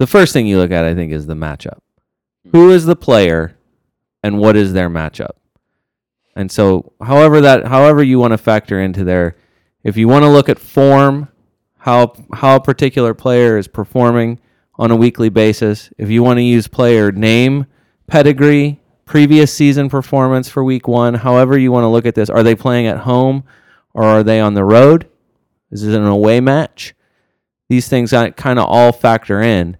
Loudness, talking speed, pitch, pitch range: -11 LUFS, 185 wpm, 120 Hz, 110-135 Hz